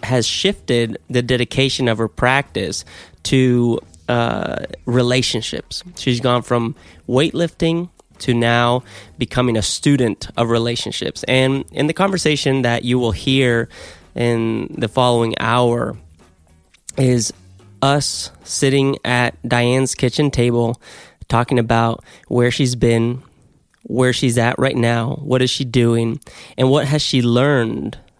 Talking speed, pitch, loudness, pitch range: 125 wpm, 120 Hz, -17 LUFS, 115-135 Hz